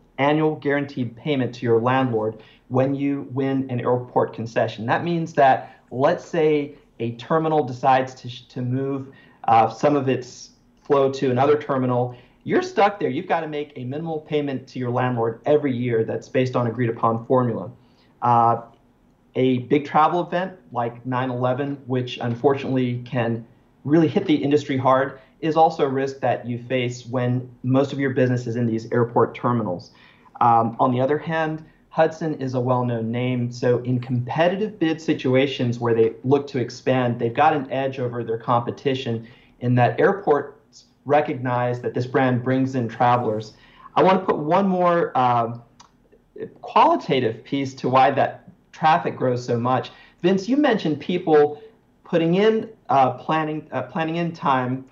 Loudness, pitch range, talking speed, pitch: -22 LUFS, 120-145 Hz, 165 wpm, 130 Hz